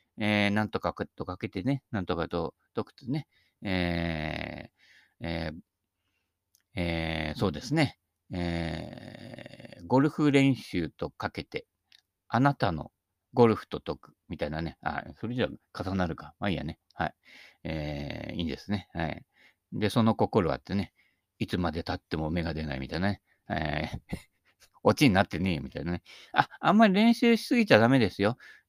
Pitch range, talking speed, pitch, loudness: 85-115 Hz, 295 characters per minute, 95 Hz, -29 LUFS